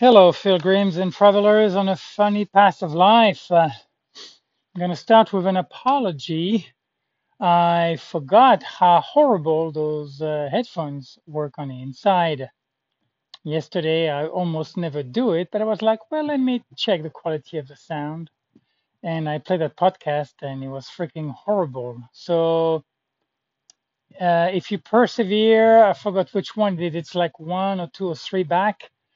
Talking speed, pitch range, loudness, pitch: 160 wpm, 155-200 Hz, -20 LUFS, 175 Hz